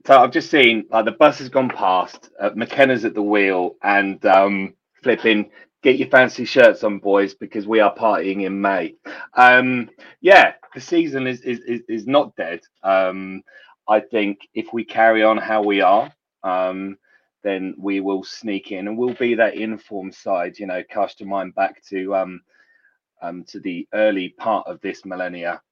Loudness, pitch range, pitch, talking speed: -18 LUFS, 95-115 Hz, 105 Hz, 180 wpm